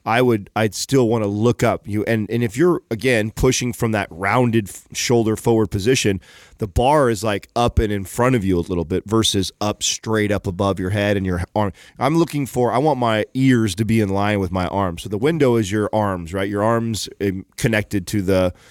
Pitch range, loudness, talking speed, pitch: 100-120 Hz, -19 LUFS, 230 wpm, 110 Hz